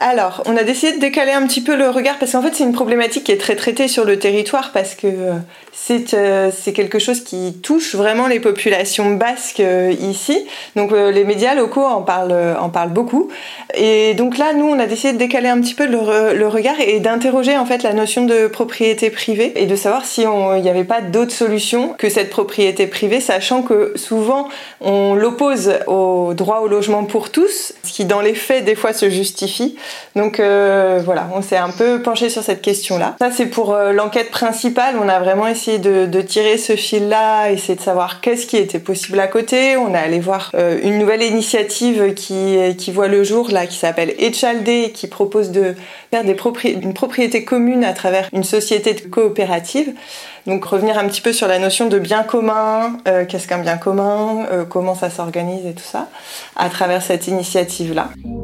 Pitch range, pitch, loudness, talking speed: 195-240 Hz, 215 Hz, -15 LUFS, 205 wpm